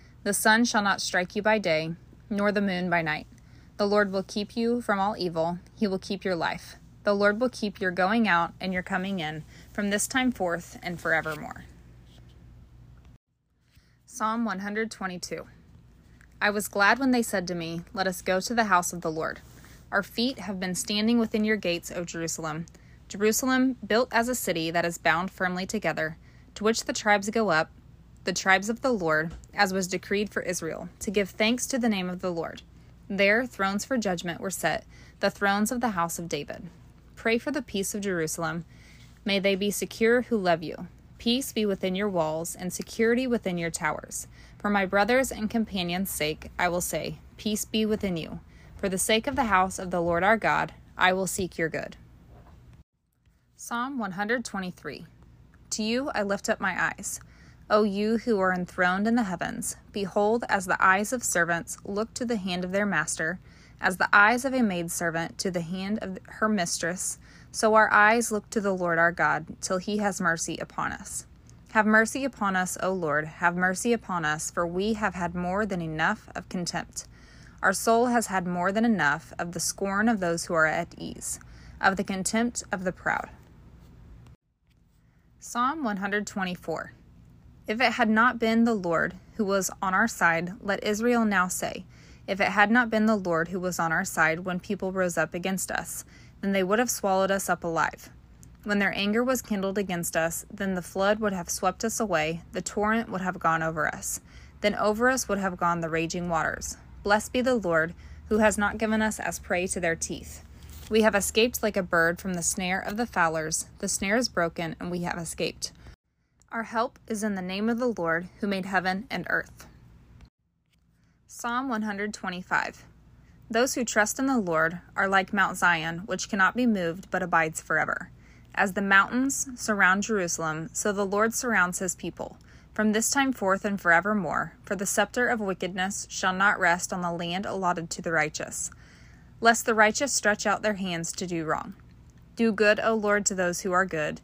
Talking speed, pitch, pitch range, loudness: 195 wpm, 195 Hz, 170-215 Hz, -26 LUFS